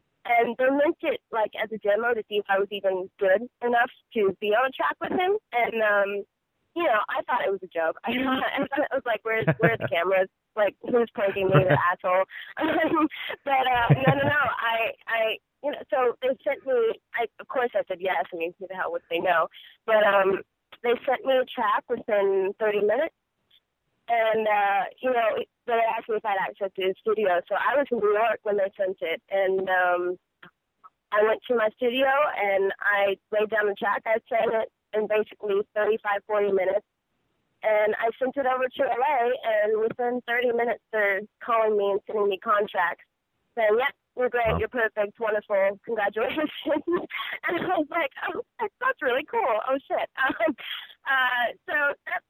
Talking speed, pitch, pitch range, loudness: 200 wpm, 220 Hz, 200-265 Hz, -25 LUFS